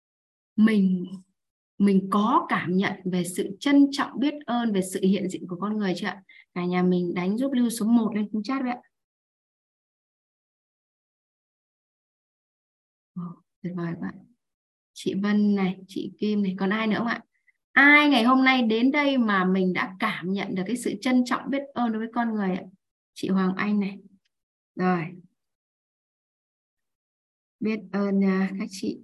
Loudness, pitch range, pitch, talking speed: -24 LUFS, 190-240 Hz, 205 Hz, 165 wpm